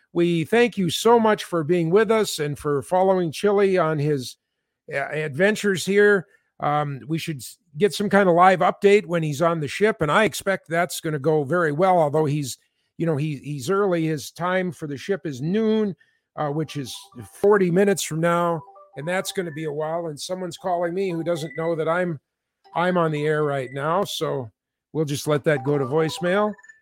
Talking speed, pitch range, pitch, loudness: 205 wpm, 150-195 Hz, 170 Hz, -22 LUFS